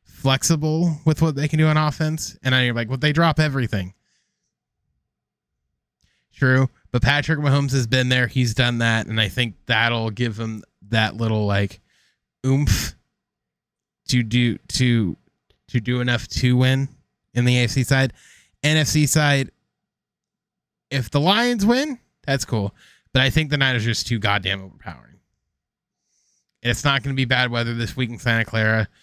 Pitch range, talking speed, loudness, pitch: 115-140 Hz, 160 wpm, -20 LUFS, 125 Hz